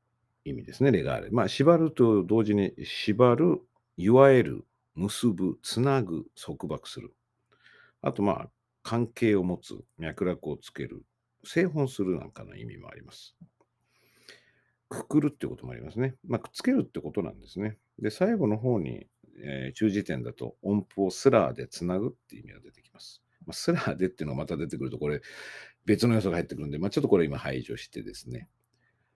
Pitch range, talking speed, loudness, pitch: 95-130 Hz, 355 characters per minute, -28 LUFS, 110 Hz